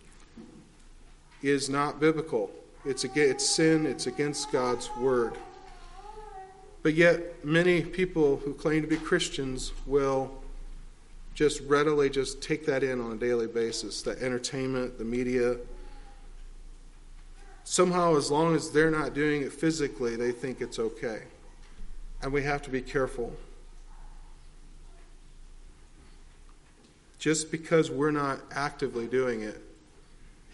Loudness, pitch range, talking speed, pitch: -28 LUFS, 125-160 Hz, 120 wpm, 145 Hz